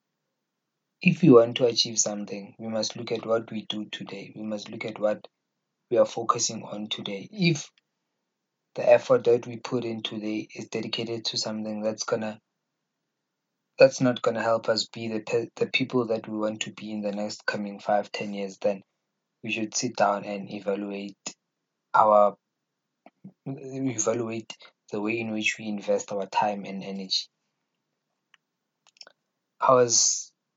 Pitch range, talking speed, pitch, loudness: 105-120 Hz, 155 wpm, 110 Hz, -26 LUFS